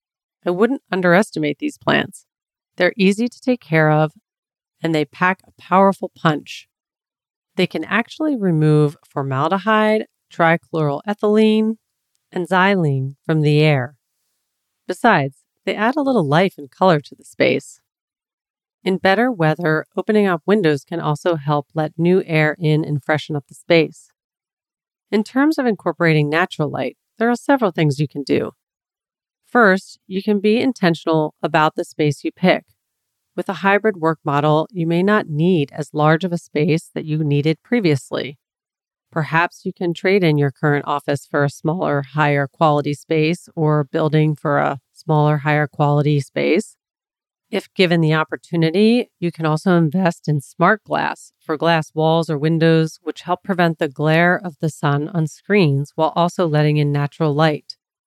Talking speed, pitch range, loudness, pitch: 155 wpm, 150-185 Hz, -18 LUFS, 160 Hz